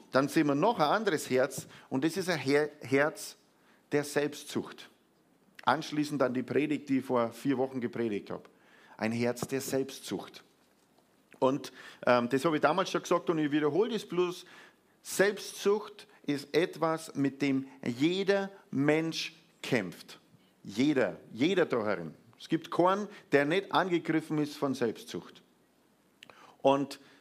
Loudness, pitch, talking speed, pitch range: -31 LUFS, 145 Hz, 140 wpm, 135-170 Hz